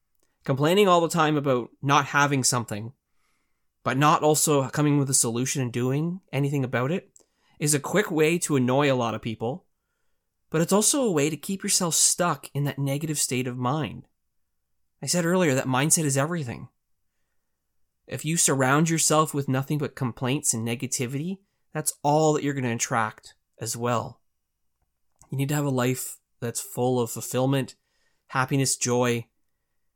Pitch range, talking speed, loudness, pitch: 120-155 Hz, 165 wpm, -24 LUFS, 135 Hz